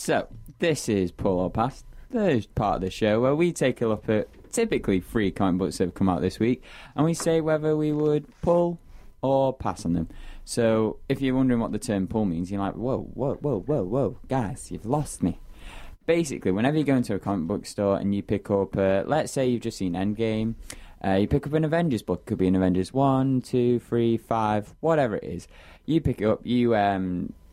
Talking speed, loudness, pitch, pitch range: 225 wpm, -25 LUFS, 110 Hz, 95-135 Hz